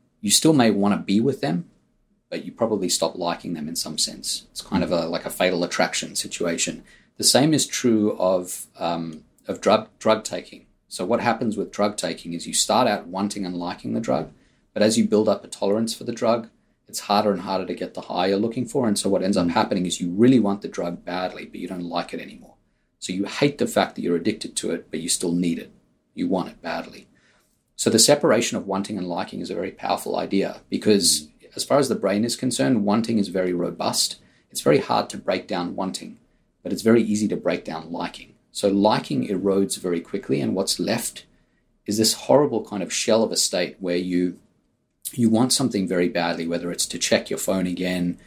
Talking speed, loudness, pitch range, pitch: 225 wpm, -22 LUFS, 90-110 Hz, 95 Hz